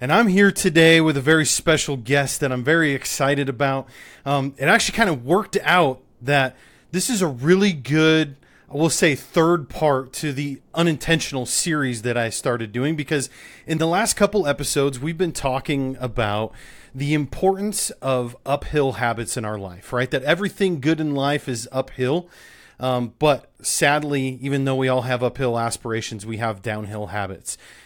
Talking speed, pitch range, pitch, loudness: 170 wpm, 125-160 Hz, 140 Hz, -21 LUFS